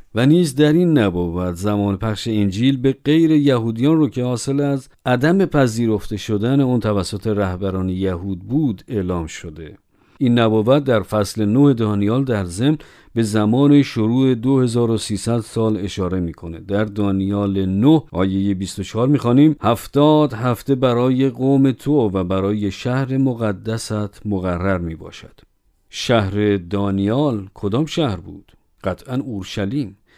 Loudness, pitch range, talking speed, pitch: -18 LUFS, 100-135 Hz, 125 wpm, 110 Hz